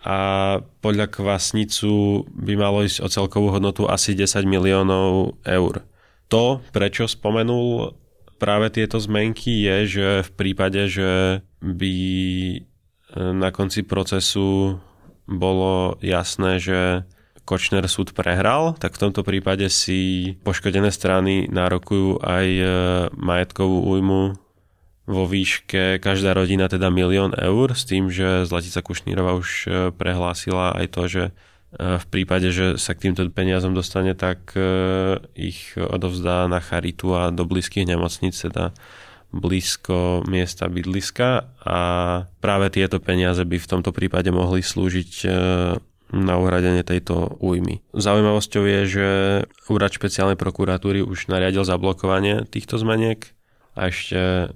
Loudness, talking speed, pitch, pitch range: -21 LUFS, 120 wpm, 95 Hz, 90-100 Hz